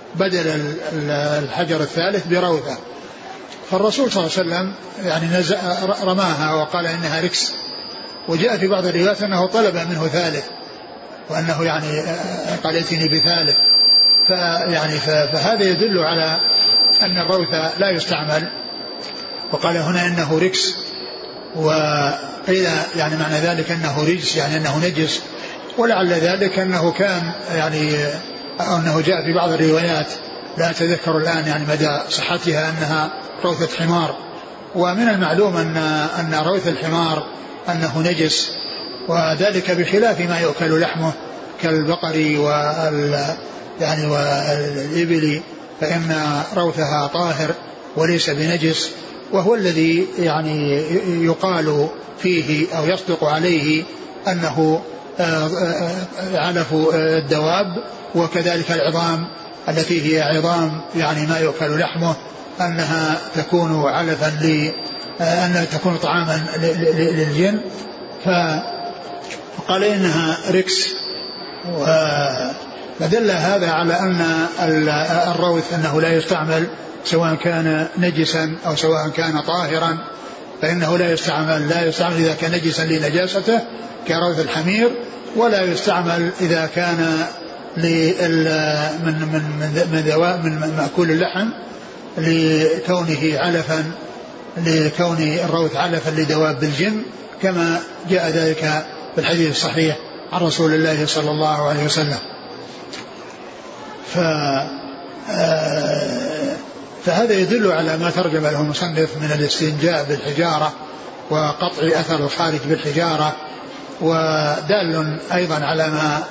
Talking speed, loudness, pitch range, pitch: 100 wpm, -18 LUFS, 155-175 Hz, 165 Hz